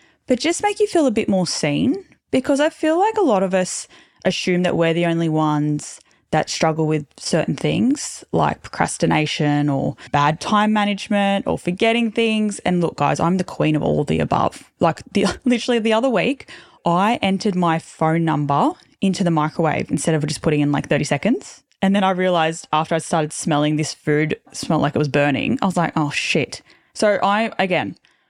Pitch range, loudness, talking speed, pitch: 155-215 Hz, -19 LUFS, 195 wpm, 175 Hz